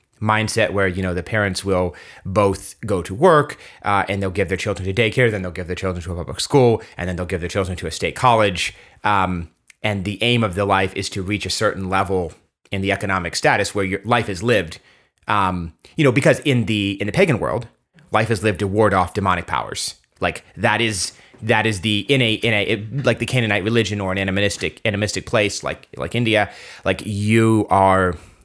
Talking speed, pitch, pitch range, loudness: 220 wpm, 100 Hz, 95-110 Hz, -19 LUFS